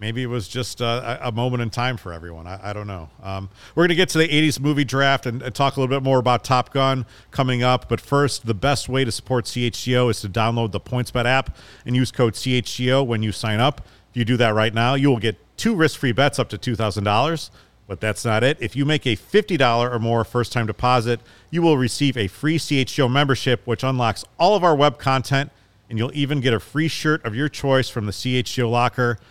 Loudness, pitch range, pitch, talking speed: -20 LUFS, 115-135 Hz, 125 Hz, 240 wpm